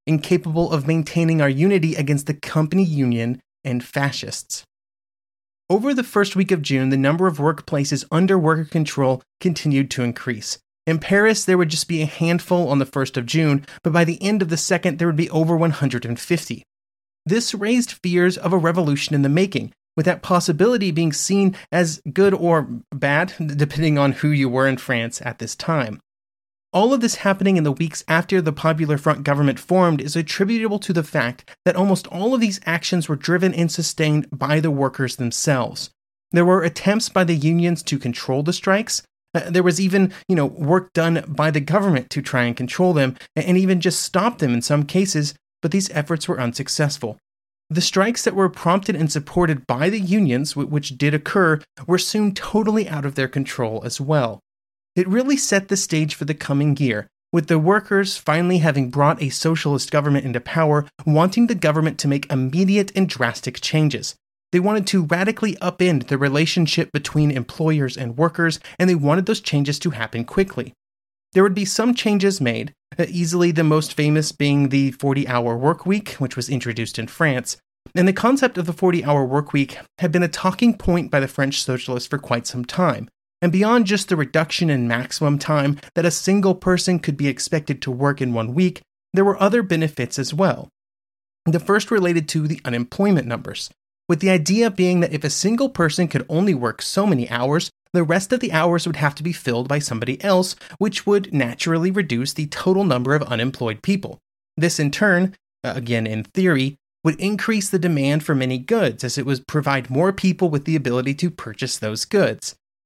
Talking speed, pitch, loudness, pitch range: 190 wpm, 160 Hz, -20 LUFS, 140-185 Hz